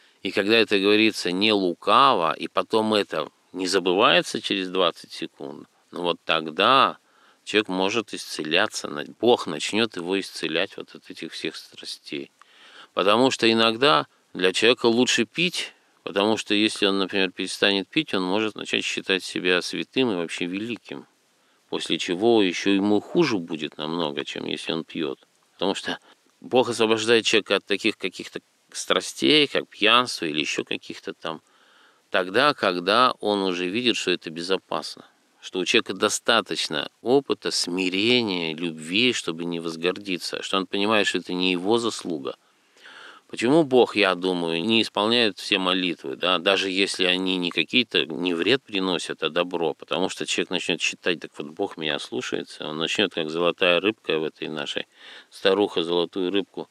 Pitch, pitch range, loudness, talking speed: 100 Hz, 90-110 Hz, -23 LUFS, 150 wpm